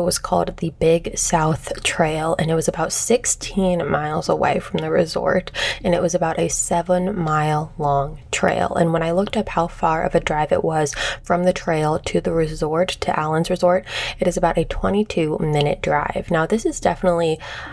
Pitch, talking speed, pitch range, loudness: 170 Hz, 195 wpm, 155-180 Hz, -20 LUFS